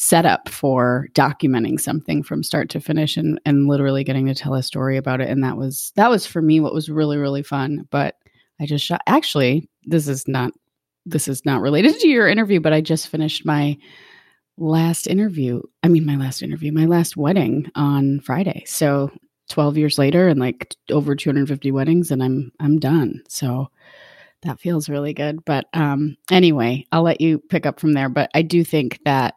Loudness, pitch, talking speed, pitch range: -19 LUFS, 150 Hz, 195 wpm, 140-160 Hz